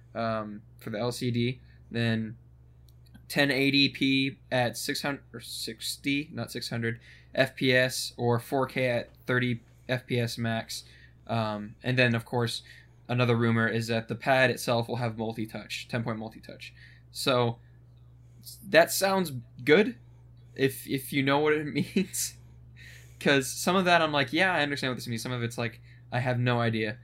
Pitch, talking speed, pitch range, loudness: 120 Hz, 170 wpm, 115-130 Hz, -28 LUFS